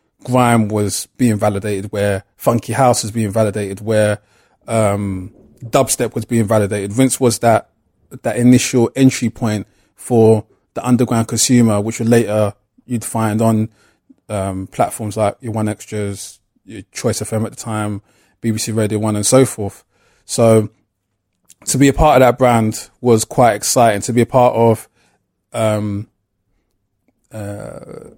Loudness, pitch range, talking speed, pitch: -16 LUFS, 105-120 Hz, 145 wpm, 110 Hz